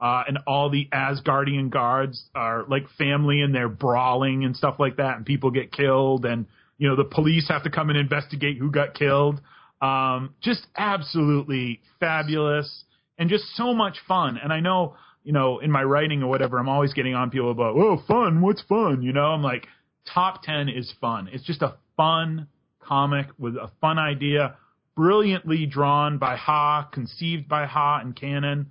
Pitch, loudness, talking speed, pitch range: 145 Hz, -23 LUFS, 185 wpm, 135-155 Hz